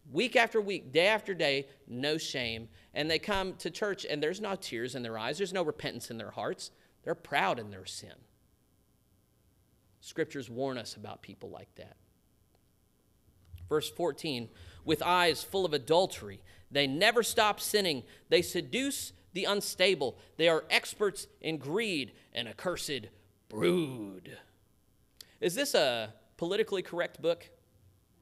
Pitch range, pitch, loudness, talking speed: 110-190 Hz, 155 Hz, -31 LUFS, 145 wpm